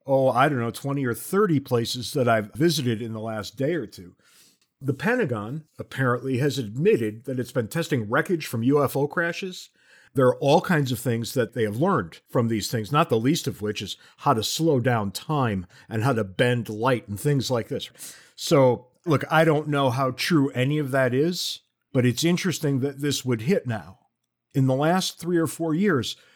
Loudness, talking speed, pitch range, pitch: -24 LUFS, 205 wpm, 120-150 Hz, 135 Hz